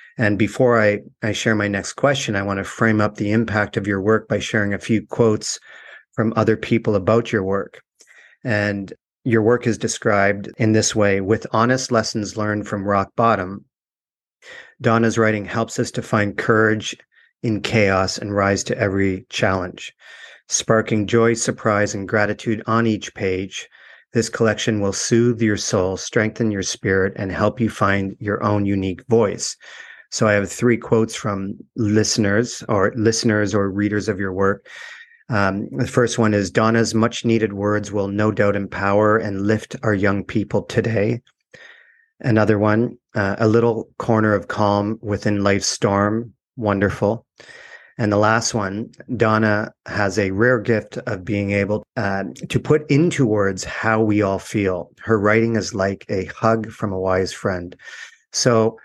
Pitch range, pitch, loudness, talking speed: 100-115 Hz, 110 Hz, -20 LUFS, 165 wpm